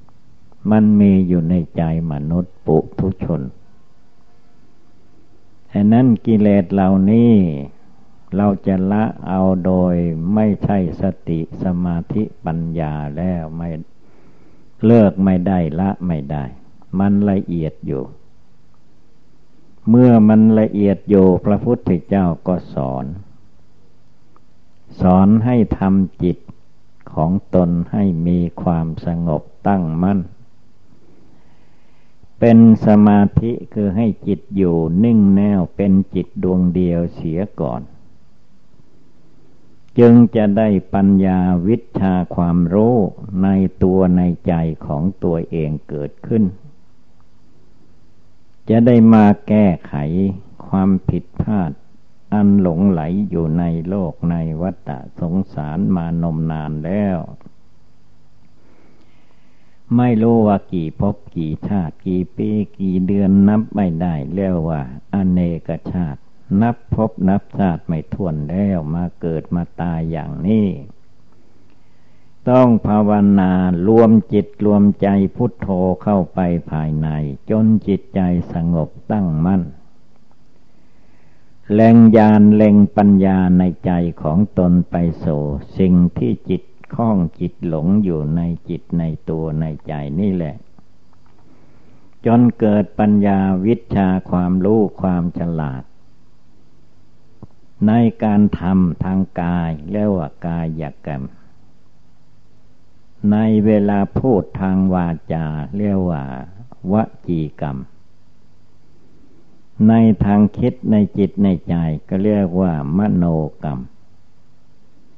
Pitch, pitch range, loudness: 95 Hz, 85-105 Hz, -16 LUFS